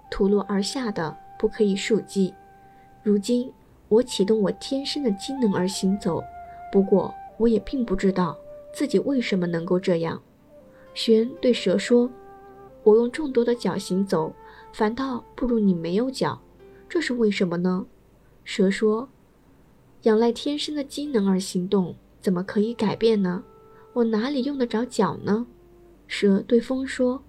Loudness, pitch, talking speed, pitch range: -24 LUFS, 215 Hz, 215 characters per minute, 190-245 Hz